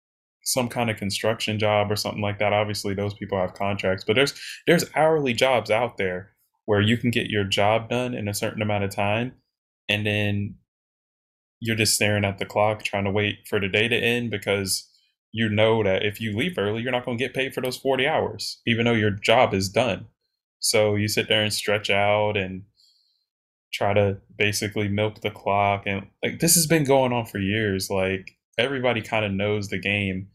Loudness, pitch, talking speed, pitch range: -23 LUFS, 105 Hz, 205 wpm, 100-115 Hz